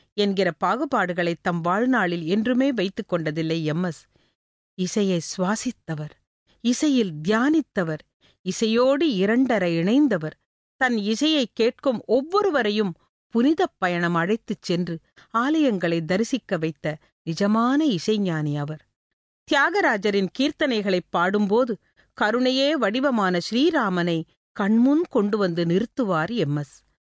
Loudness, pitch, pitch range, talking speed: -23 LUFS, 210 Hz, 175-255 Hz, 90 wpm